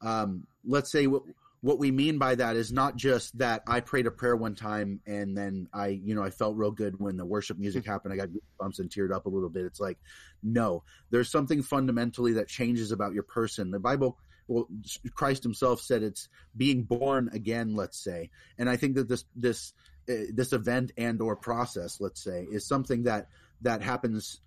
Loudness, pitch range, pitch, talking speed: -30 LUFS, 100-125 Hz, 115 Hz, 205 wpm